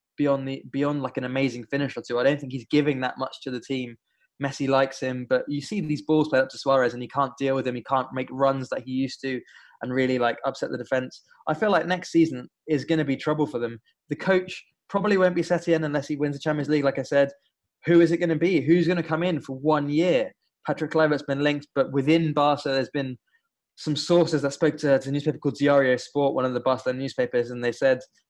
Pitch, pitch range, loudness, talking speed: 140 Hz, 130-155 Hz, -25 LUFS, 250 wpm